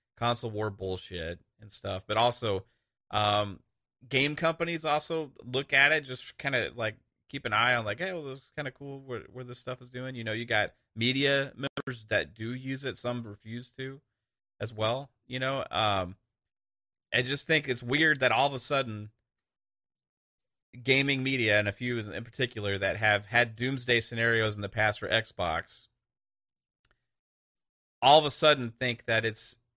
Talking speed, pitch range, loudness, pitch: 180 wpm, 110-135 Hz, -29 LUFS, 120 Hz